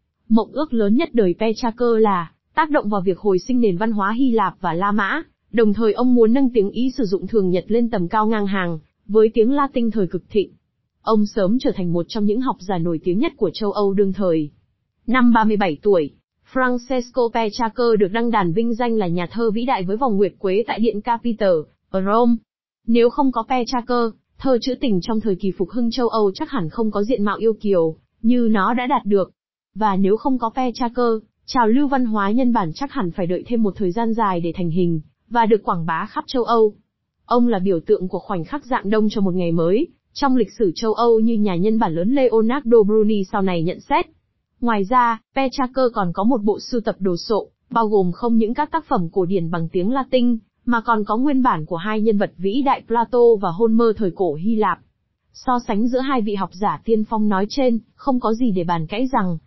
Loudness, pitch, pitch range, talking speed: -19 LUFS, 220 Hz, 195-240 Hz, 230 wpm